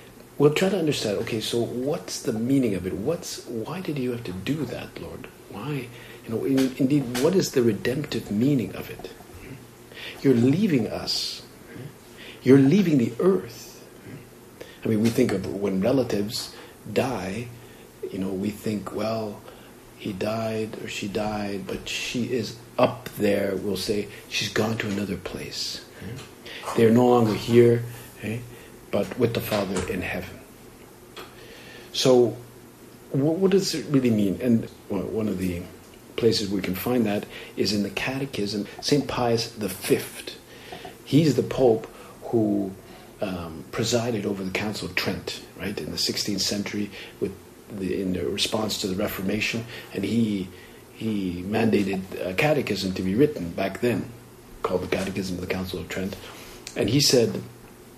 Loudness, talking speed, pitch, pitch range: -25 LUFS, 155 wpm, 115 Hz, 100-125 Hz